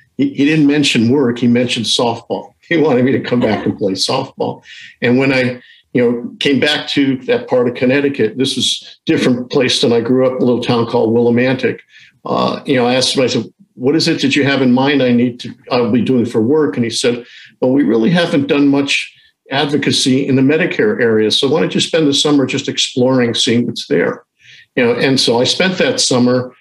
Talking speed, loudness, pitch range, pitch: 225 wpm, -14 LUFS, 120-145 Hz, 130 Hz